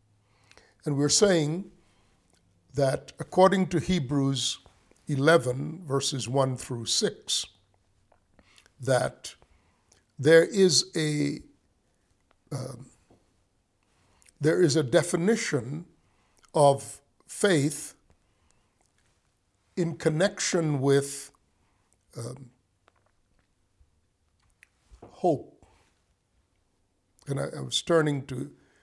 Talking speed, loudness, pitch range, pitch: 70 wpm, -26 LUFS, 95-150 Hz, 125 Hz